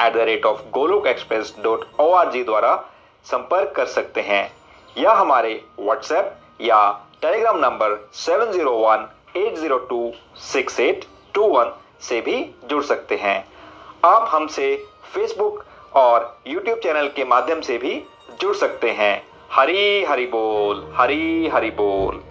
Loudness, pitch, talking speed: -19 LUFS, 230 Hz, 145 wpm